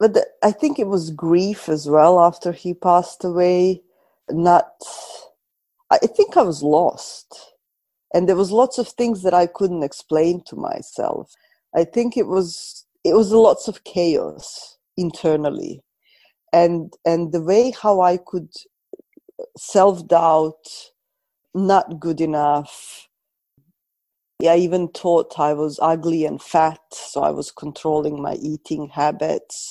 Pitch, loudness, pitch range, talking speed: 175 Hz, -19 LUFS, 160-210 Hz, 135 wpm